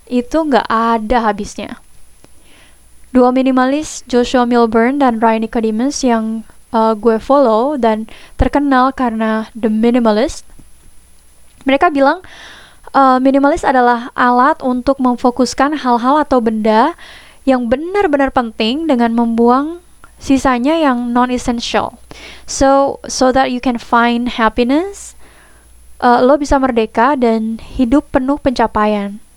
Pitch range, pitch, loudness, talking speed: 230-275 Hz, 250 Hz, -13 LUFS, 110 wpm